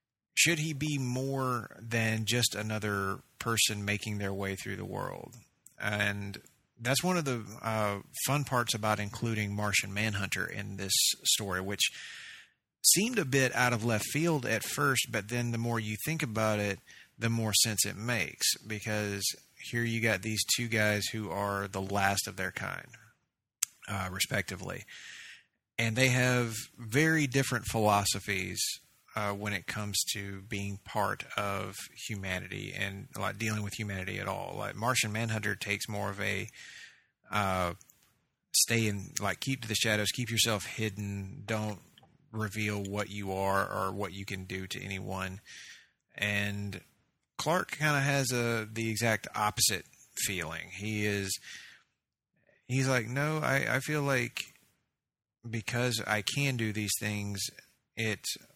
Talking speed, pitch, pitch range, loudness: 150 wpm, 110 Hz, 100-120 Hz, -31 LUFS